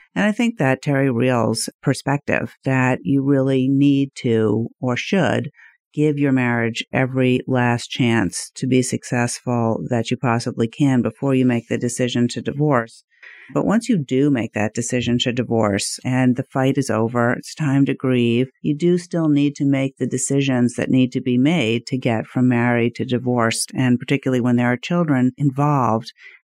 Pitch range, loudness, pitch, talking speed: 120-140 Hz, -19 LUFS, 125 Hz, 175 wpm